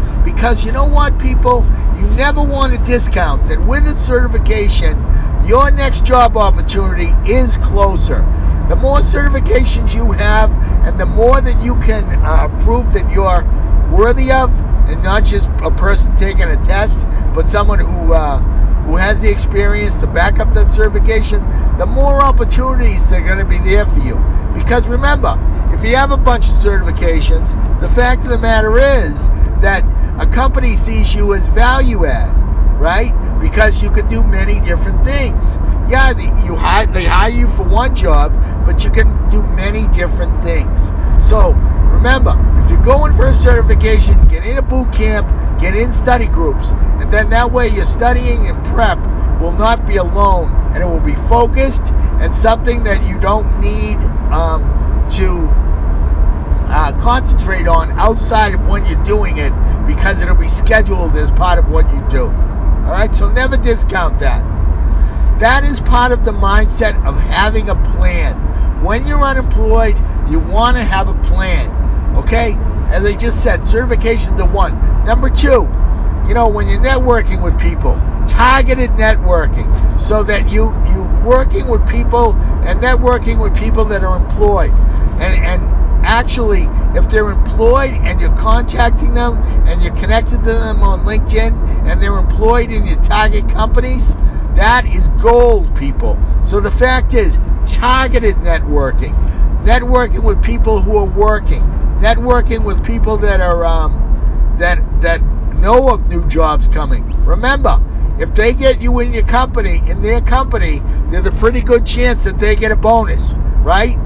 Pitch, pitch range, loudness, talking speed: 75 Hz, 75-90 Hz, -13 LUFS, 160 wpm